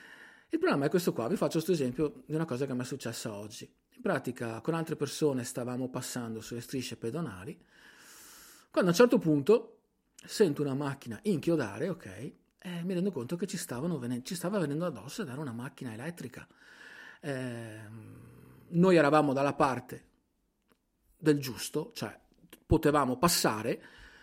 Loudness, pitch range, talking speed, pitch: -31 LUFS, 125-170 Hz, 155 wpm, 145 Hz